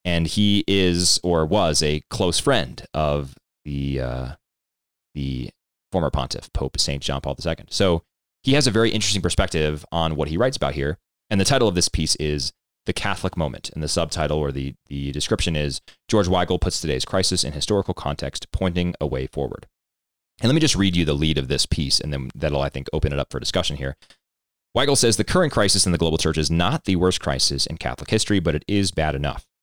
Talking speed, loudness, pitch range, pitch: 215 wpm, -22 LUFS, 70-90 Hz, 80 Hz